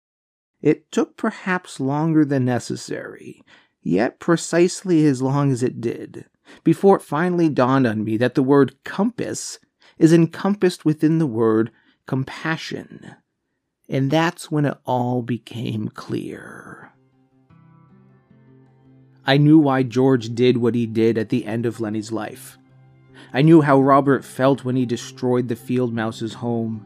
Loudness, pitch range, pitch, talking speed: -20 LUFS, 120-155 Hz, 130 Hz, 140 wpm